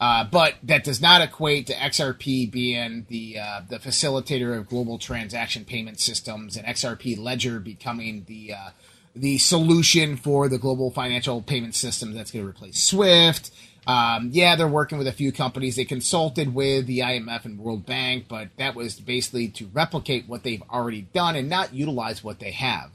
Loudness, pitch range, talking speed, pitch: -22 LUFS, 115-140 Hz, 180 wpm, 125 Hz